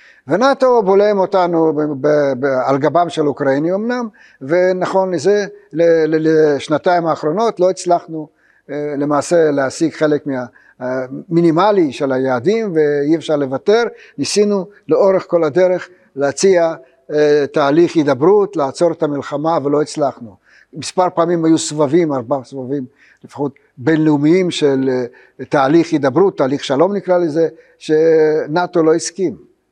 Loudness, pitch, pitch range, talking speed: -15 LUFS, 160 Hz, 145-180 Hz, 115 wpm